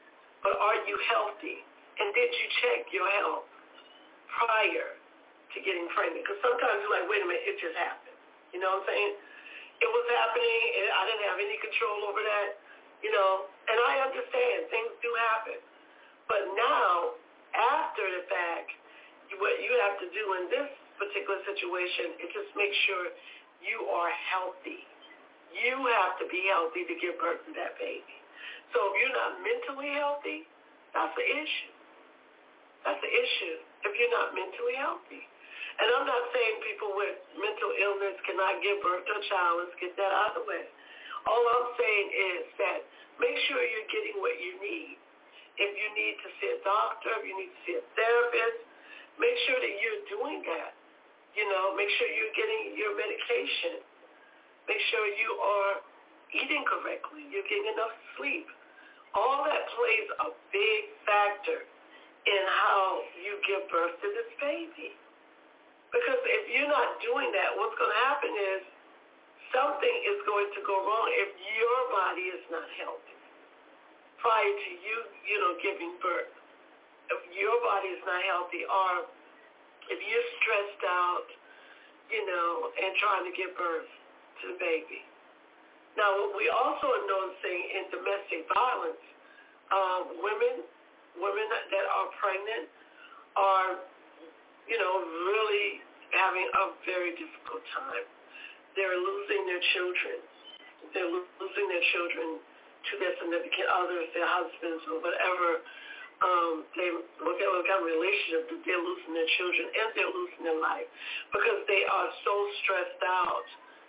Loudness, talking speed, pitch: -30 LUFS, 155 wpm, 270 Hz